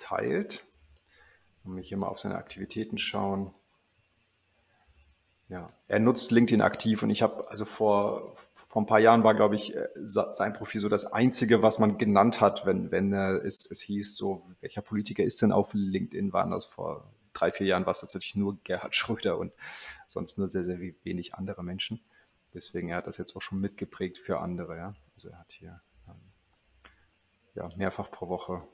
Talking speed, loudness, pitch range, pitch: 180 wpm, -29 LUFS, 95-110 Hz, 100 Hz